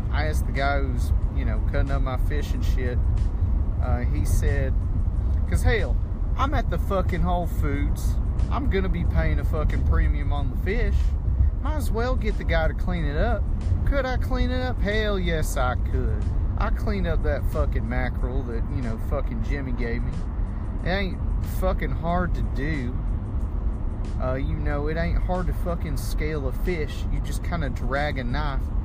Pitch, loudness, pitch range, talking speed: 85 Hz, -26 LUFS, 75-90 Hz, 190 wpm